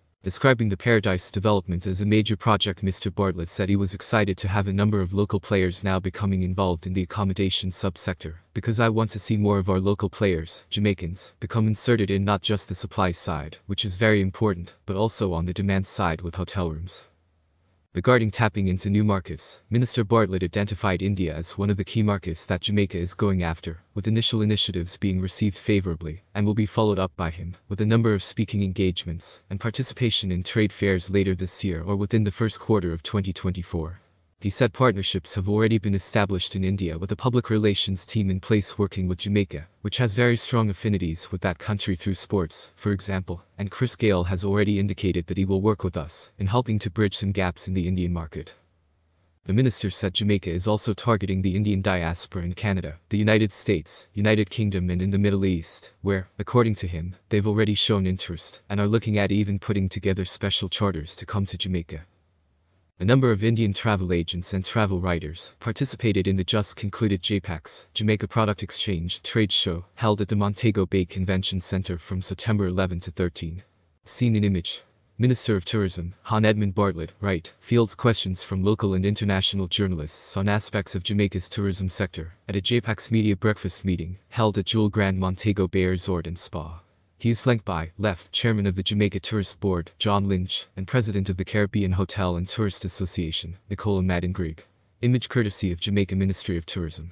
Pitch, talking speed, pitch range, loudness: 100 Hz, 190 wpm, 90-105 Hz, -25 LUFS